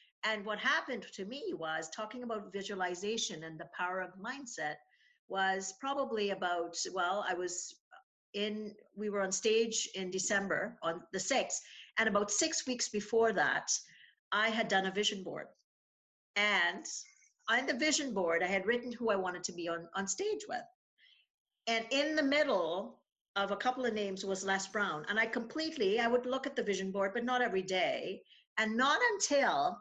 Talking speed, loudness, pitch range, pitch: 175 wpm, -34 LUFS, 190-250 Hz, 210 Hz